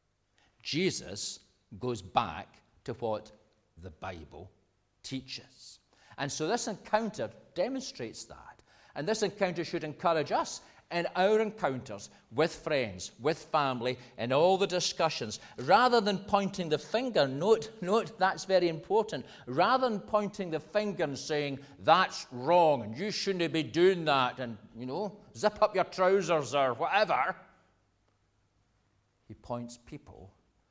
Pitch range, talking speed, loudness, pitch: 115-190 Hz, 135 wpm, -30 LUFS, 150 Hz